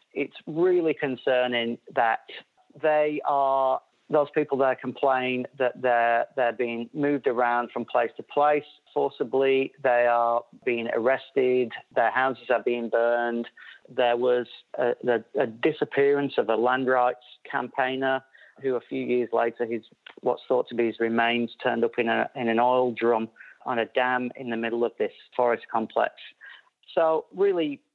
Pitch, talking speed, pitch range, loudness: 125 Hz, 160 wpm, 120-135 Hz, -25 LUFS